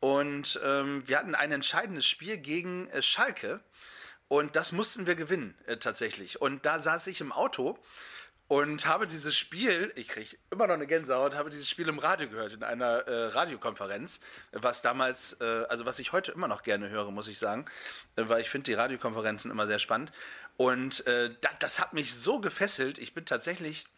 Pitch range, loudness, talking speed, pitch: 130-160 Hz, -30 LUFS, 195 wpm, 145 Hz